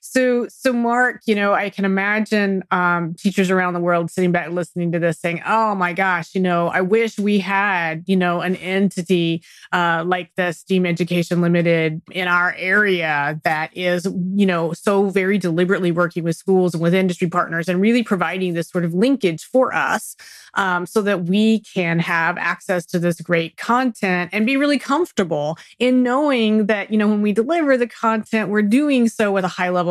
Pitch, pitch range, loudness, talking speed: 185 Hz, 175-215 Hz, -19 LUFS, 195 wpm